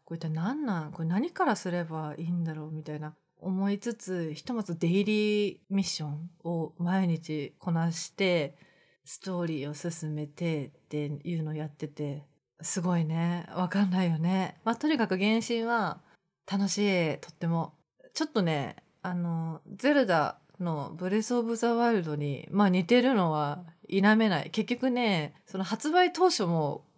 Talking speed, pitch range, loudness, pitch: 305 characters per minute, 160-205 Hz, -30 LUFS, 175 Hz